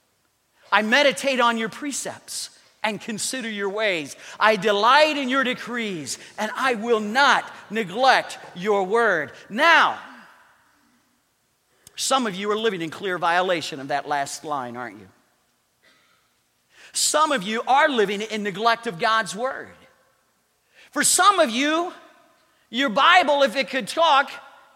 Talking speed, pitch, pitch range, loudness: 135 wpm, 235 Hz, 205-275 Hz, -21 LUFS